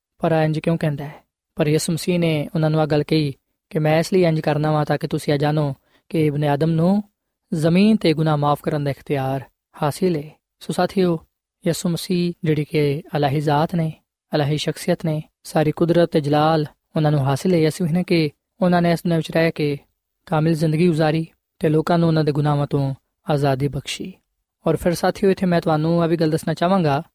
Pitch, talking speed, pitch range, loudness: 160 Hz, 195 wpm, 150-170 Hz, -20 LUFS